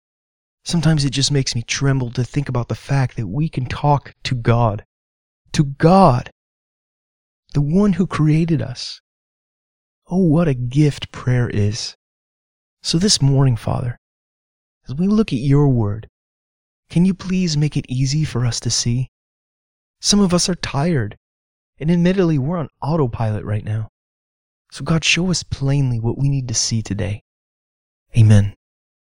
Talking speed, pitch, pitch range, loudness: 155 wpm, 130 Hz, 110-155 Hz, -18 LUFS